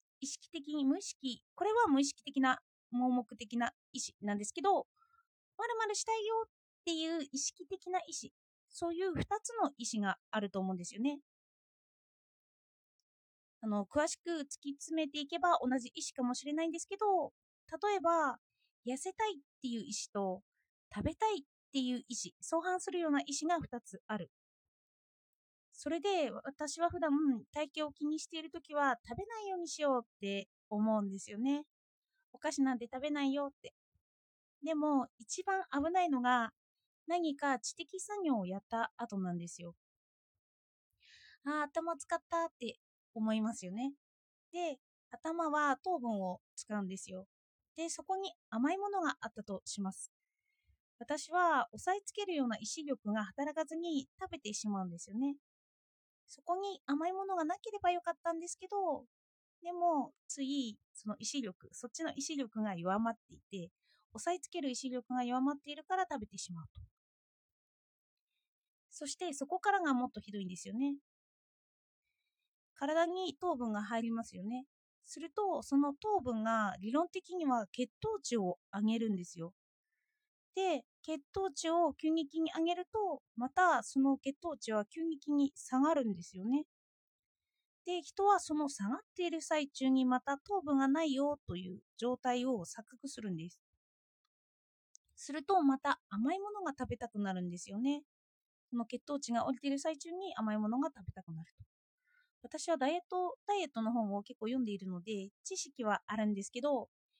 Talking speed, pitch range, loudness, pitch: 305 characters per minute, 230-340 Hz, -37 LUFS, 280 Hz